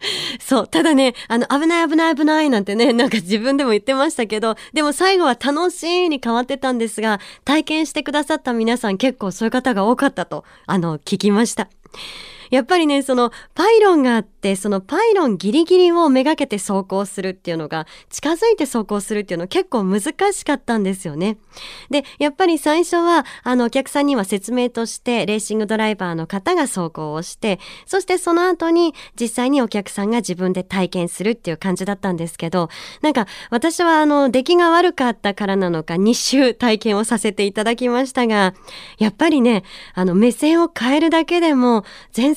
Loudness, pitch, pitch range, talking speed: -18 LUFS, 240 Hz, 205-300 Hz, 390 characters per minute